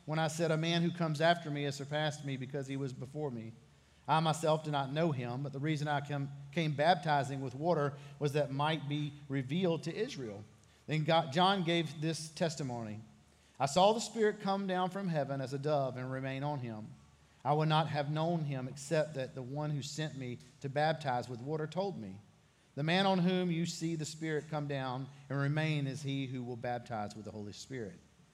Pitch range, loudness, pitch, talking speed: 130-160 Hz, -35 LUFS, 145 Hz, 210 wpm